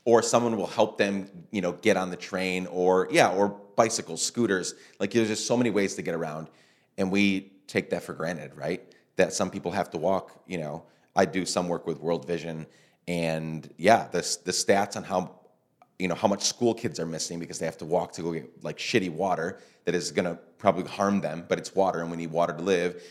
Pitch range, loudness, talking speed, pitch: 85-100 Hz, -27 LUFS, 230 wpm, 90 Hz